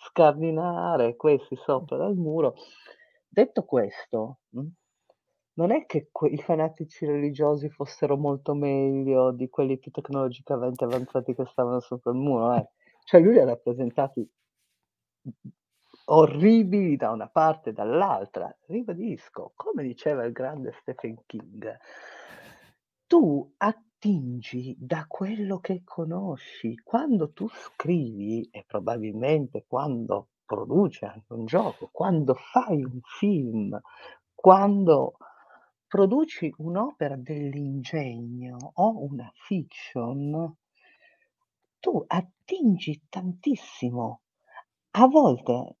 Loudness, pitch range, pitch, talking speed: -25 LUFS, 130-185 Hz, 150 Hz, 100 wpm